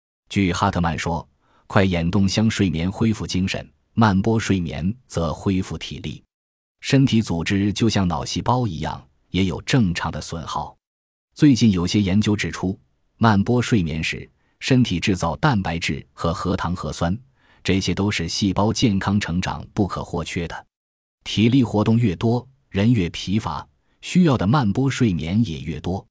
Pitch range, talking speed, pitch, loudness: 85-115 Hz, 235 characters per minute, 100 Hz, -21 LUFS